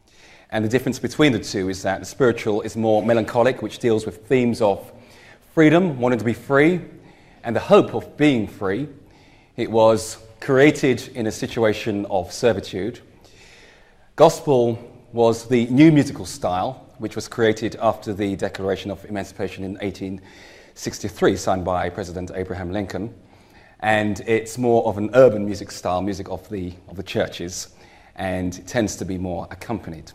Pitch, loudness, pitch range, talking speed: 110 Hz, -21 LUFS, 95-120 Hz, 155 wpm